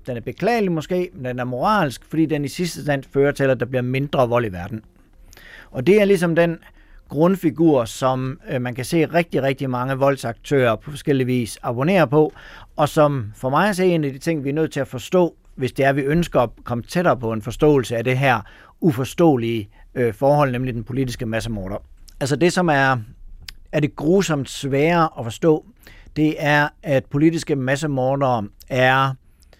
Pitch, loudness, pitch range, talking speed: 135 Hz, -20 LUFS, 125-155 Hz, 190 wpm